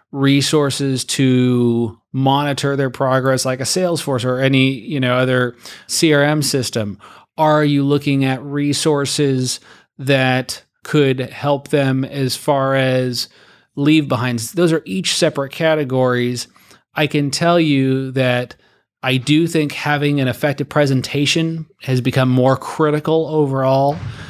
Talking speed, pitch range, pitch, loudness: 125 wpm, 130-150 Hz, 135 Hz, -17 LUFS